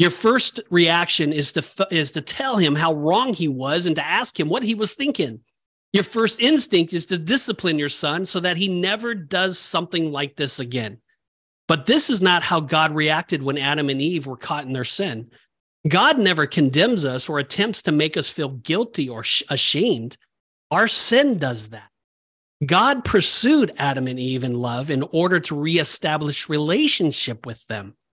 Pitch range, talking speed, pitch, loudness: 140-190 Hz, 185 wpm, 160 Hz, -19 LUFS